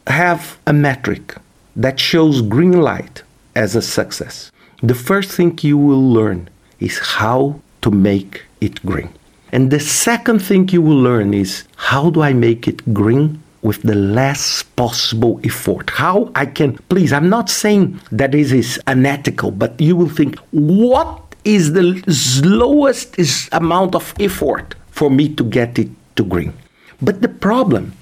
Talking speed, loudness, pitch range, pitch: 160 wpm, -15 LUFS, 120-175 Hz, 145 Hz